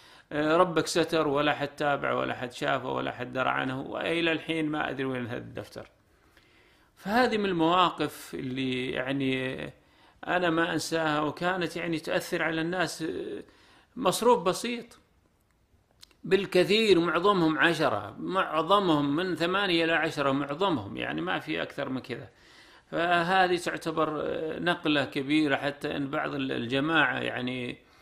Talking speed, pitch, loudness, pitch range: 125 wpm, 160 Hz, -28 LUFS, 140-180 Hz